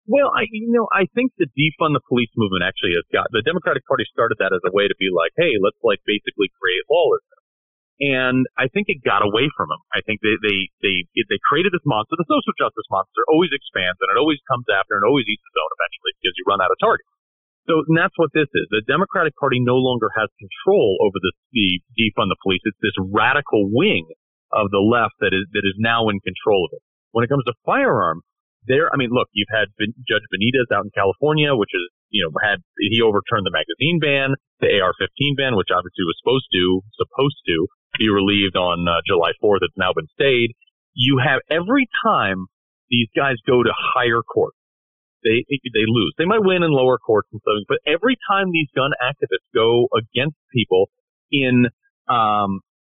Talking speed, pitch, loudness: 210 wpm, 135 Hz, -19 LUFS